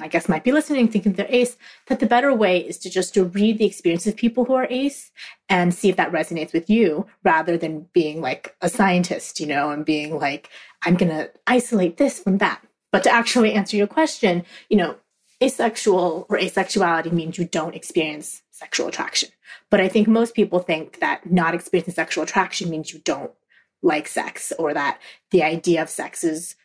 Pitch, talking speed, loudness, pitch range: 185 Hz, 200 wpm, -21 LUFS, 165-220 Hz